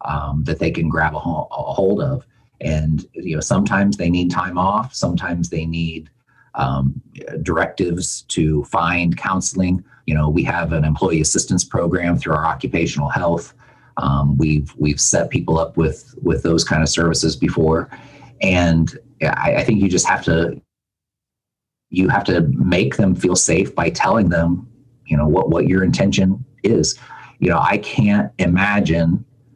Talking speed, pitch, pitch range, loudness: 160 wpm, 85 Hz, 80-95 Hz, -18 LUFS